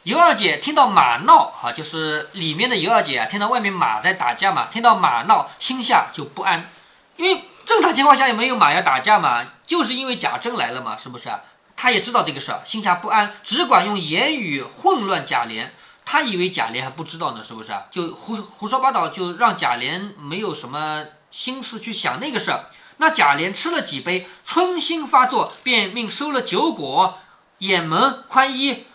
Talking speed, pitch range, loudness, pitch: 290 characters per minute, 180-275 Hz, -18 LUFS, 230 Hz